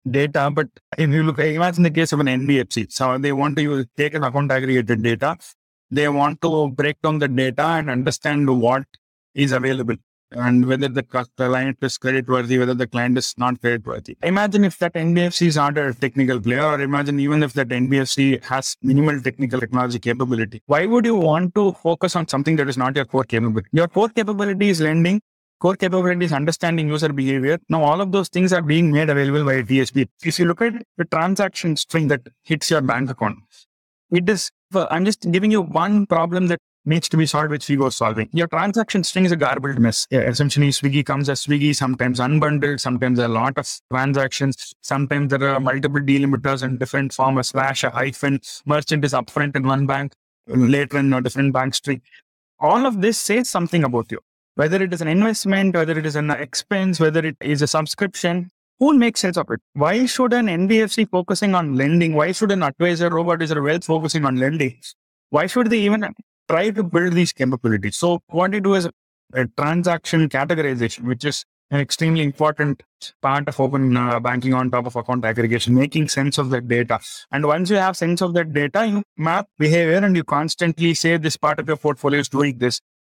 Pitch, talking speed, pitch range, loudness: 145 Hz, 205 wpm, 130-170 Hz, -19 LUFS